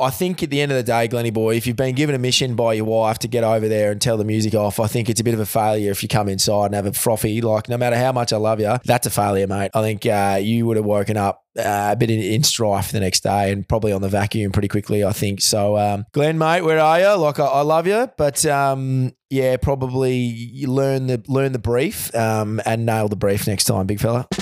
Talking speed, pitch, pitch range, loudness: 280 wpm, 115 Hz, 105-130 Hz, -19 LUFS